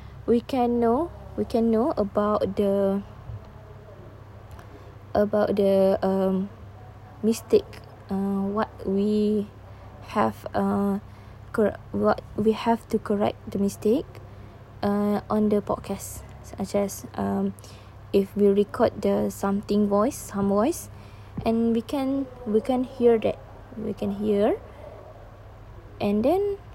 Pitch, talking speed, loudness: 195 Hz, 115 wpm, -25 LUFS